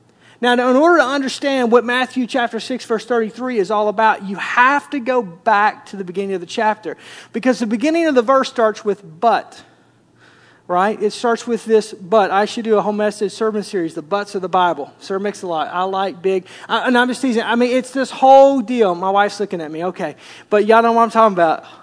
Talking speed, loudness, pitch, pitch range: 235 wpm, -17 LUFS, 220 Hz, 195-245 Hz